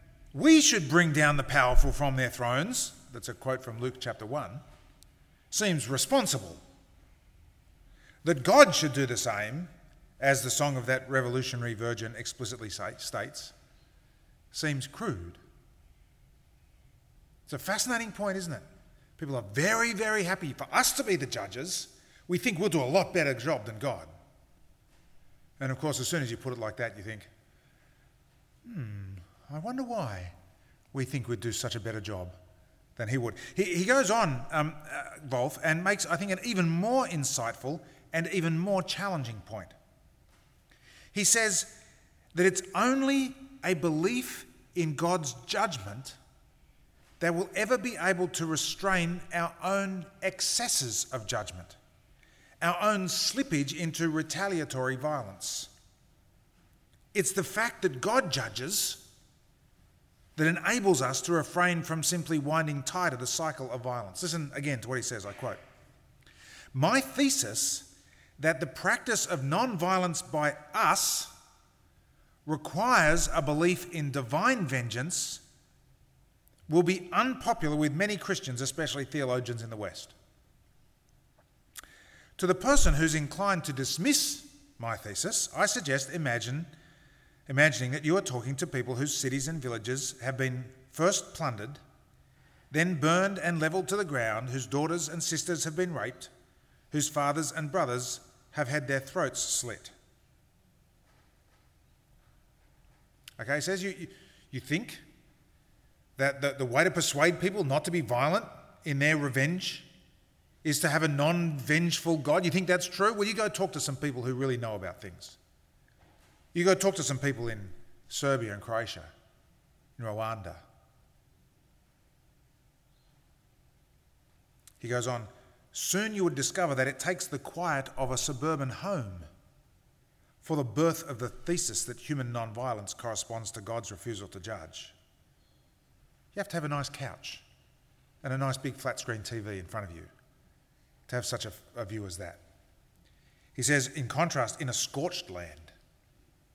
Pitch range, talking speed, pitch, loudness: 120-175 Hz, 150 wpm, 145 Hz, -30 LUFS